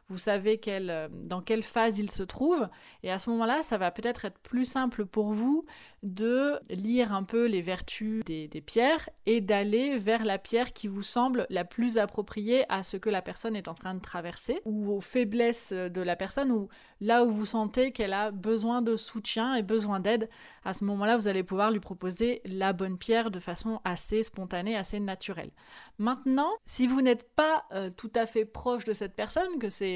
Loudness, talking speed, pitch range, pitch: -30 LUFS, 205 wpm, 195-235 Hz, 220 Hz